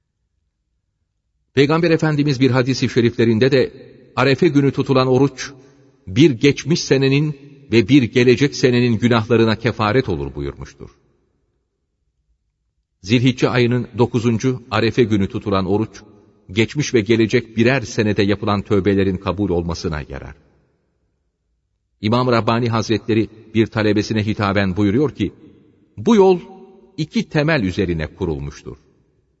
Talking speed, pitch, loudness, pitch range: 105 wpm, 115 Hz, -17 LUFS, 100-130 Hz